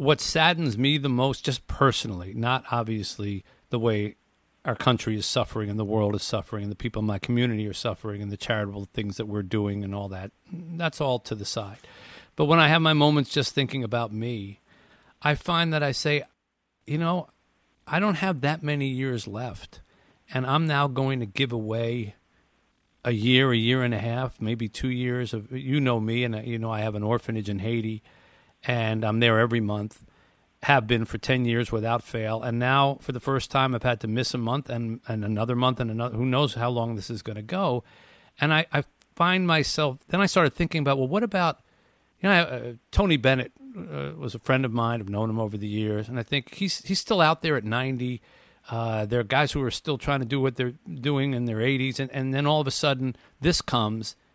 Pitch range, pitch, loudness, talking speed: 110-140 Hz, 120 Hz, -26 LUFS, 220 wpm